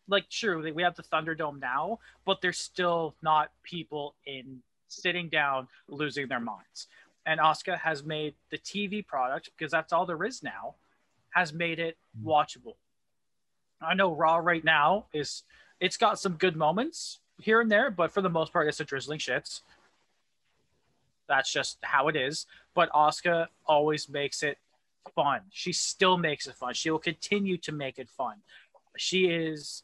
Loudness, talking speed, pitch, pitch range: -29 LUFS, 170 wpm, 160 Hz, 150-180 Hz